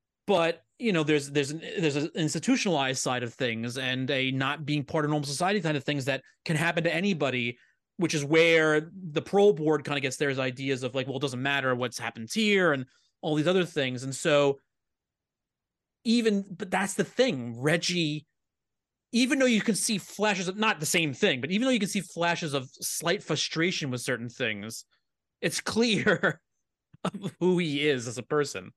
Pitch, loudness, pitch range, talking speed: 155 Hz, -27 LUFS, 135-185 Hz, 195 wpm